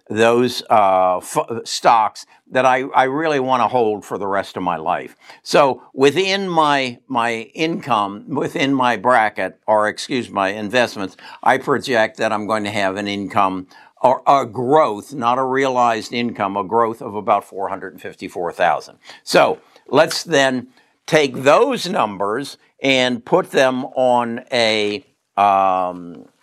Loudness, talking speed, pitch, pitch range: -18 LUFS, 150 wpm, 120 Hz, 105-130 Hz